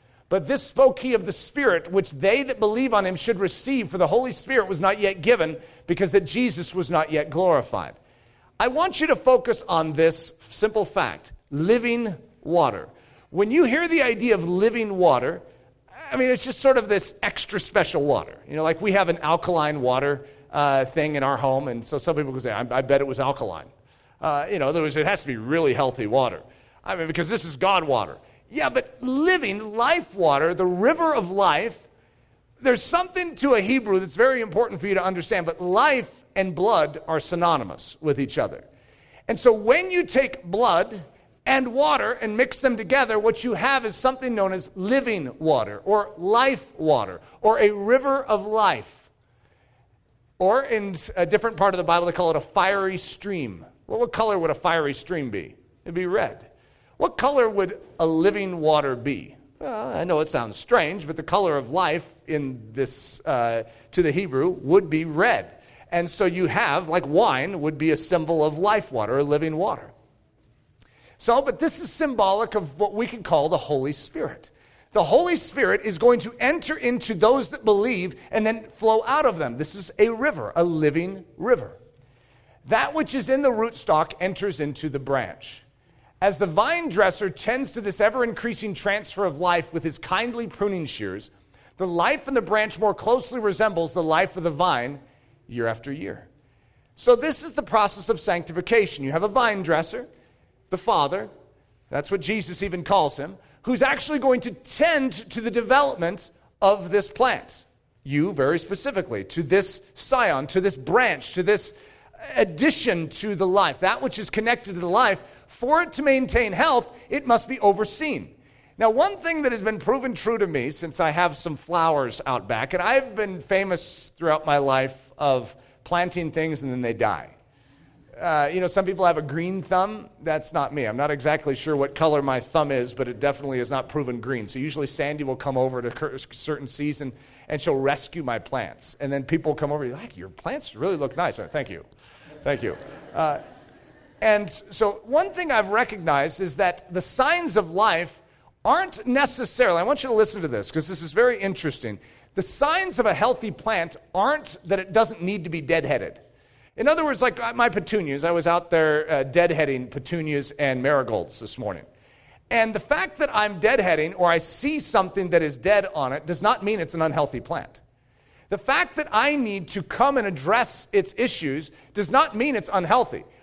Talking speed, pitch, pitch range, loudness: 195 wpm, 185 Hz, 150-230 Hz, -23 LUFS